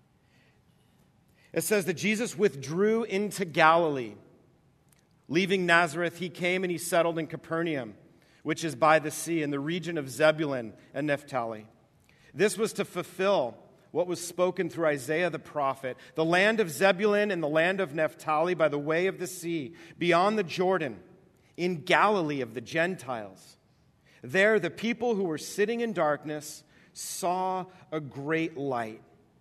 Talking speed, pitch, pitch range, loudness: 150 wpm, 165 Hz, 150-185 Hz, -28 LUFS